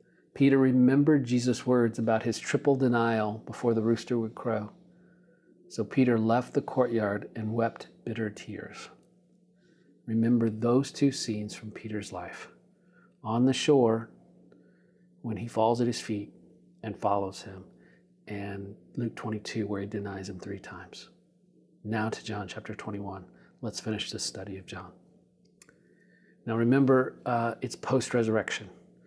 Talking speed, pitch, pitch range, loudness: 140 wpm, 115 Hz, 105-130 Hz, -29 LUFS